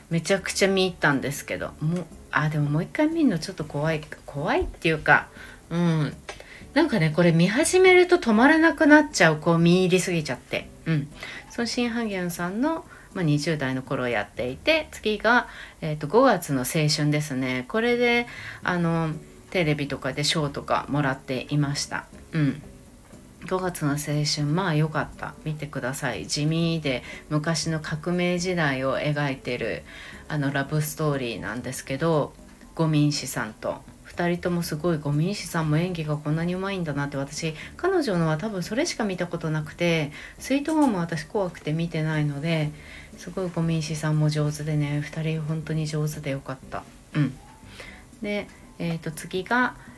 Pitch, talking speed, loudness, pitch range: 160 Hz, 335 characters per minute, -25 LUFS, 145-185 Hz